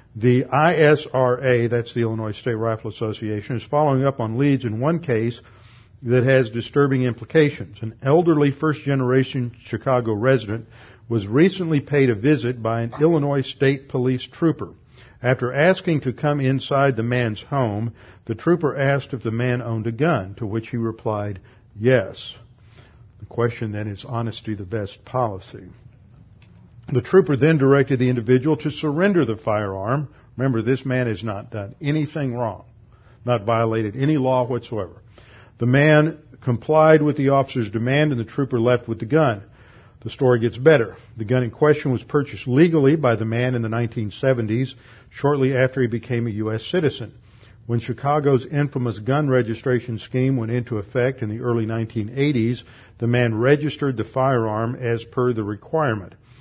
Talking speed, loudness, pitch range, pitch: 160 wpm, -21 LUFS, 115-135 Hz, 125 Hz